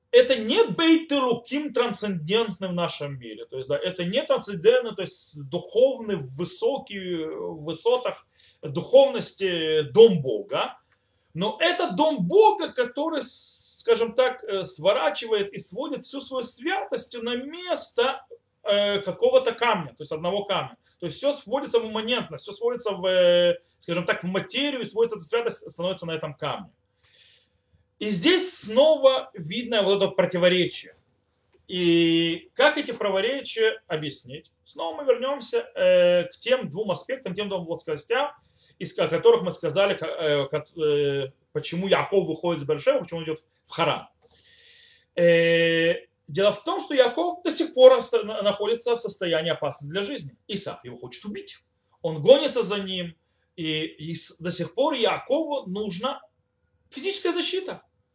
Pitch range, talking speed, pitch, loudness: 170-270 Hz, 140 wpm, 205 Hz, -24 LUFS